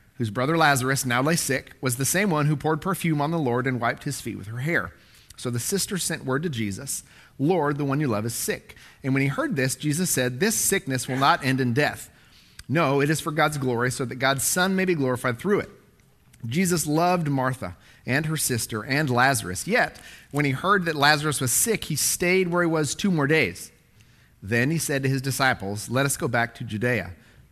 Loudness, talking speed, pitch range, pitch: -24 LUFS, 220 wpm, 125-160 Hz, 135 Hz